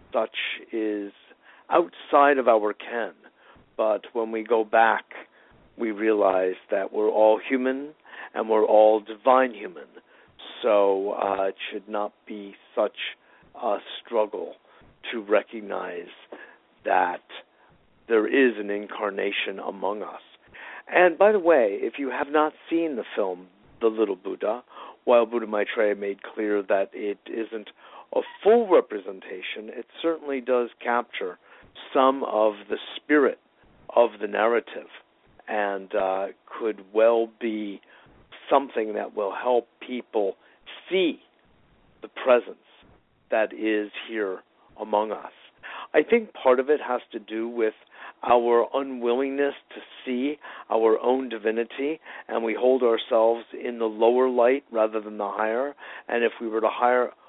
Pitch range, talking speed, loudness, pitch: 105-130 Hz, 135 wpm, -24 LUFS, 115 Hz